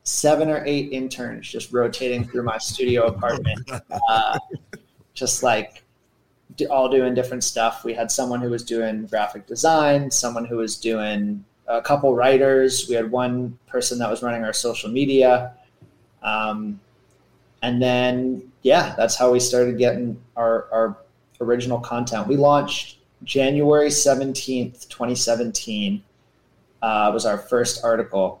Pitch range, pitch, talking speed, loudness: 115-130 Hz, 125 Hz, 140 wpm, -21 LUFS